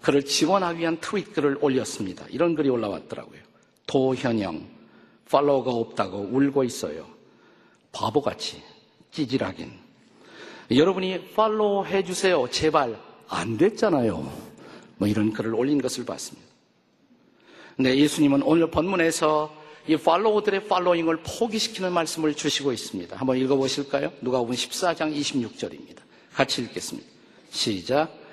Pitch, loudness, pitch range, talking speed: 150 Hz, -24 LUFS, 130-180 Hz, 310 characters per minute